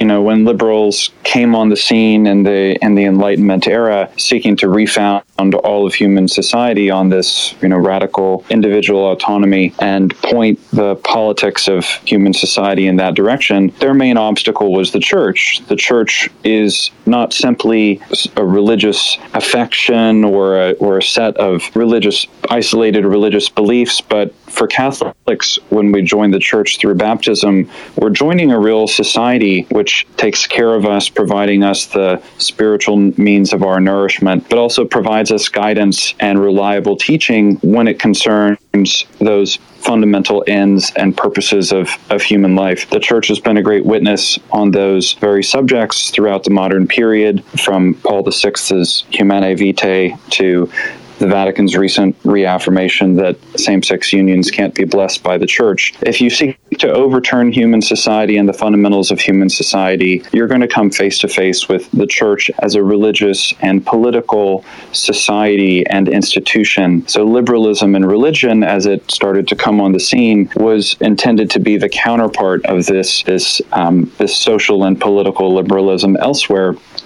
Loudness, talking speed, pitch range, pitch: -11 LUFS, 160 wpm, 95-110 Hz, 100 Hz